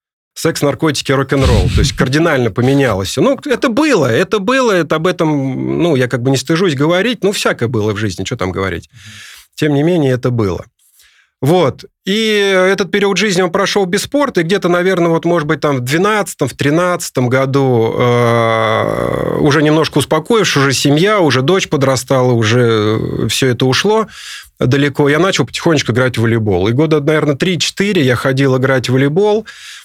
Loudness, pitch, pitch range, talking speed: -13 LUFS, 145 Hz, 125-185 Hz, 170 wpm